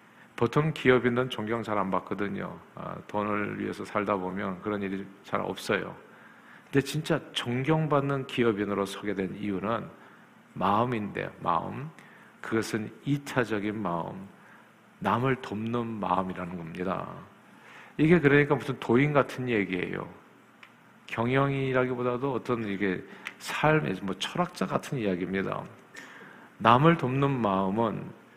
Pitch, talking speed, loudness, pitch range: 115 Hz, 265 characters per minute, -28 LUFS, 100-140 Hz